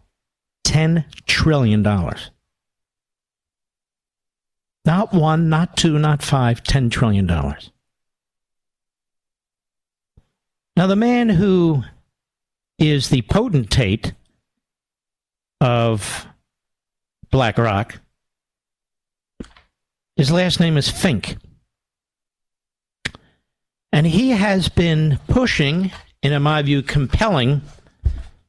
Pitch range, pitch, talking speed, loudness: 115-165 Hz, 145 Hz, 70 wpm, -18 LUFS